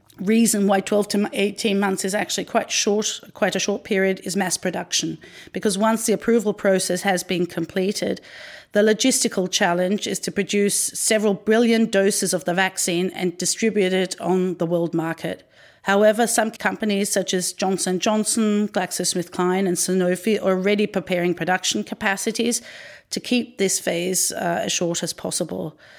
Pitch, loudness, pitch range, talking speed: 195 Hz, -21 LUFS, 185-215 Hz, 155 wpm